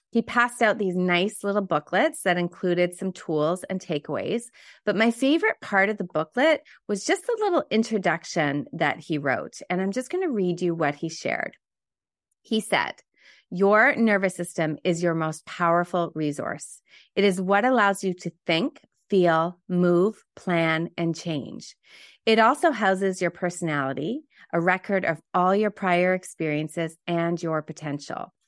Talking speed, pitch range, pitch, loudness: 160 wpm, 165-210 Hz, 180 Hz, -24 LUFS